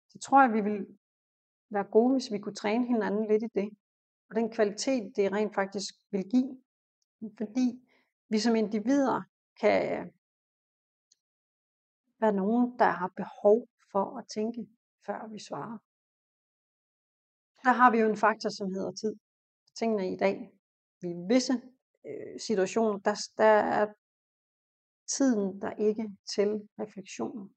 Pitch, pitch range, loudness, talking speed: 215 Hz, 205-240 Hz, -29 LUFS, 135 wpm